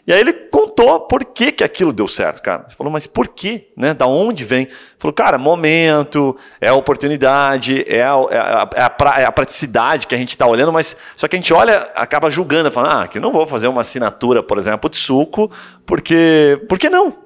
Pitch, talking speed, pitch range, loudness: 160 Hz, 230 wpm, 140-215 Hz, -14 LUFS